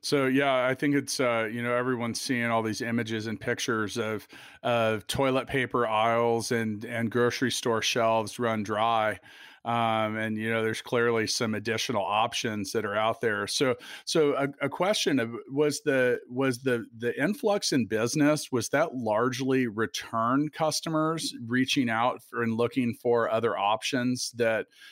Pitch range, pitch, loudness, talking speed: 115-130 Hz, 120 Hz, -27 LUFS, 165 wpm